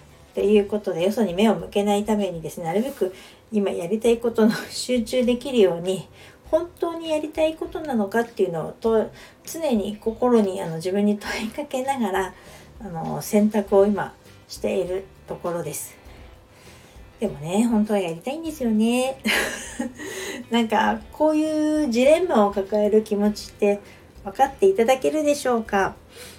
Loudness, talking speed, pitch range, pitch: -23 LUFS, 320 characters per minute, 195-255 Hz, 210 Hz